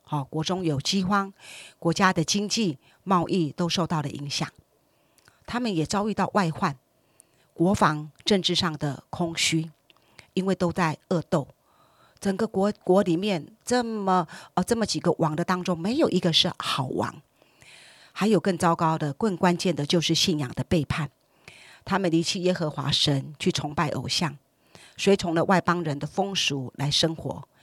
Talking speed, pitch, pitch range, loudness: 230 characters per minute, 170 Hz, 155-190 Hz, -25 LUFS